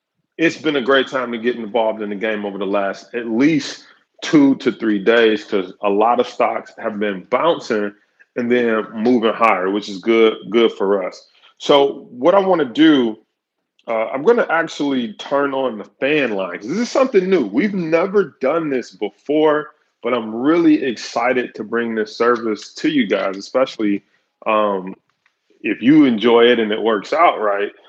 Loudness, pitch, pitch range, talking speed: -17 LUFS, 120 Hz, 110-180 Hz, 185 wpm